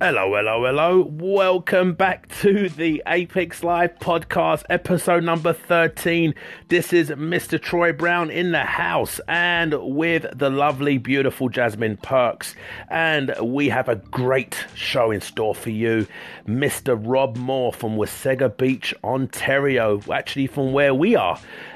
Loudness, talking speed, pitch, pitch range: -21 LUFS, 140 wpm, 150 Hz, 130-175 Hz